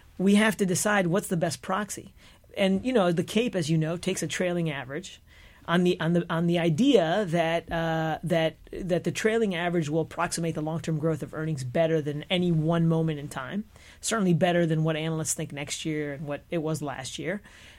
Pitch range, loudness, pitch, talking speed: 155-180 Hz, -27 LUFS, 165 Hz, 210 wpm